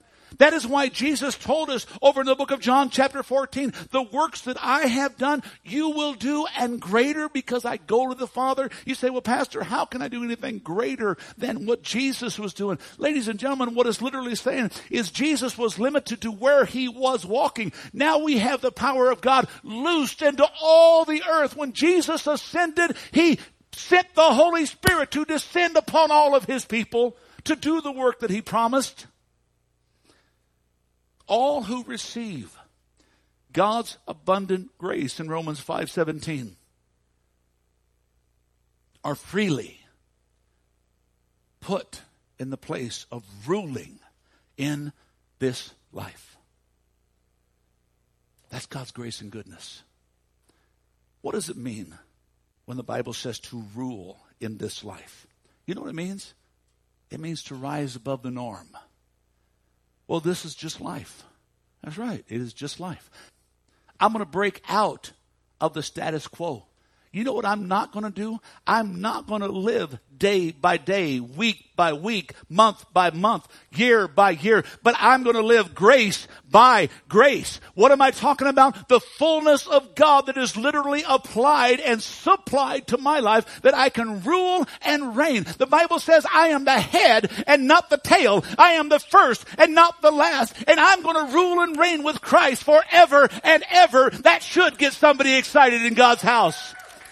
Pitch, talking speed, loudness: 235 Hz, 160 wpm, -20 LUFS